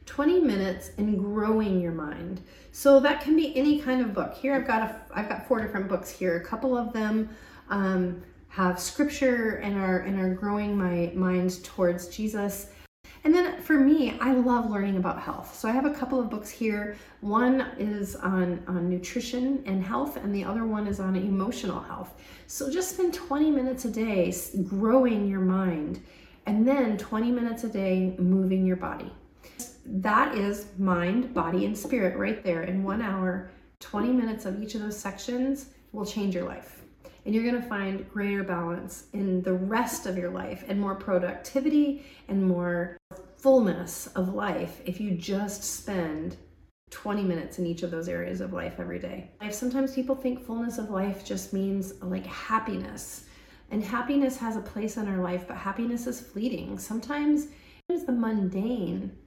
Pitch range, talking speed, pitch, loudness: 185-245 Hz, 180 wpm, 205 Hz, -28 LUFS